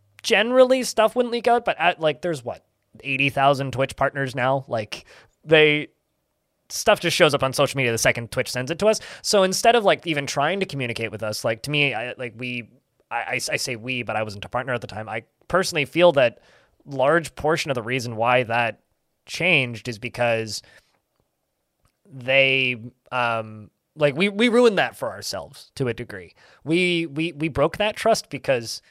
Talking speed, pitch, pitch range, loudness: 190 wpm, 135 Hz, 120-165 Hz, -21 LUFS